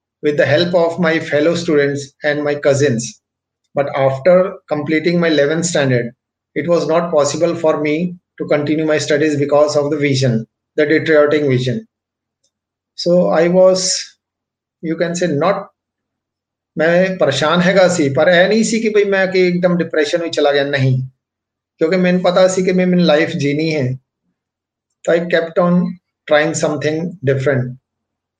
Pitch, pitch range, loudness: 150 Hz, 135-175 Hz, -15 LUFS